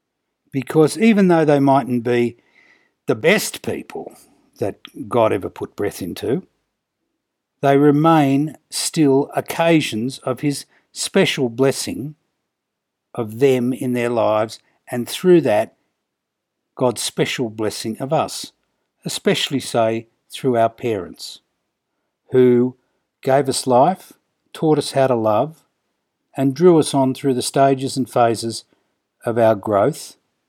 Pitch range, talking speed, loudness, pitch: 120-145 Hz, 120 wpm, -18 LUFS, 135 Hz